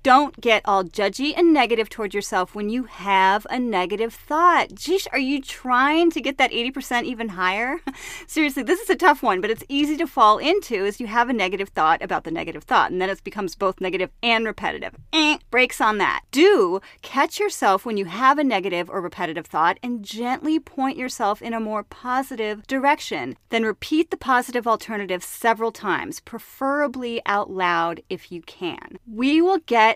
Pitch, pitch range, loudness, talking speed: 240 Hz, 205-285 Hz, -21 LUFS, 190 wpm